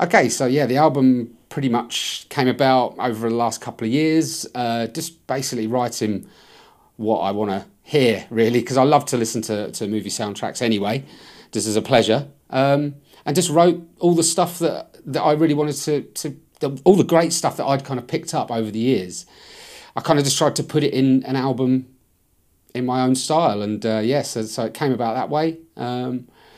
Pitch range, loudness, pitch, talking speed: 115-150 Hz, -20 LUFS, 130 Hz, 210 wpm